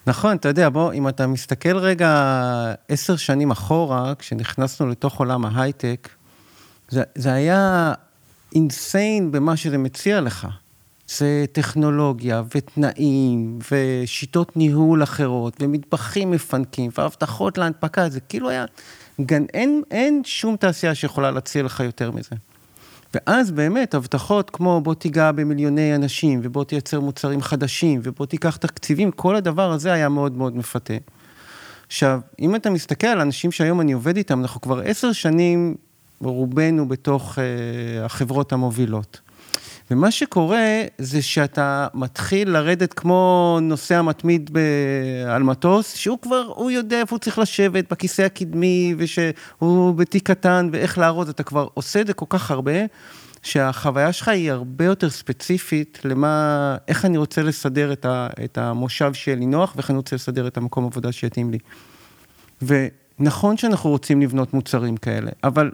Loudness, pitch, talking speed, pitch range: -20 LUFS, 145 Hz, 140 wpm, 130-175 Hz